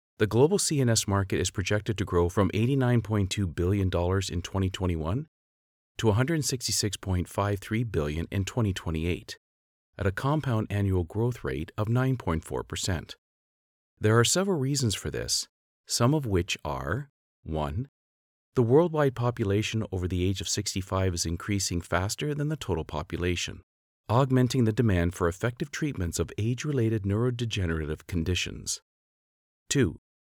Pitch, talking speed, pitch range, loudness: 100 Hz, 125 wpm, 85-120 Hz, -28 LUFS